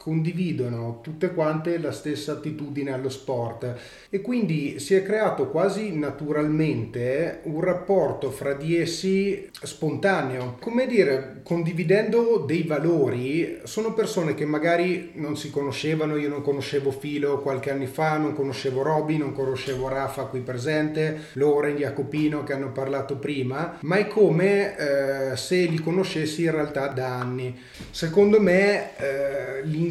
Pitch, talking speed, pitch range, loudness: 150 Hz, 135 wpm, 135-170 Hz, -25 LUFS